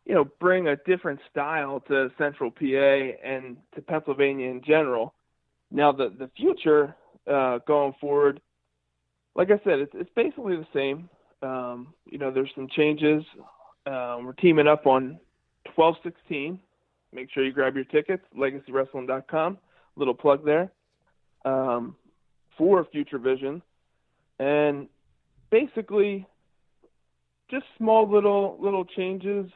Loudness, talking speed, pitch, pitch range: -25 LUFS, 125 wpm, 145 Hz, 130-175 Hz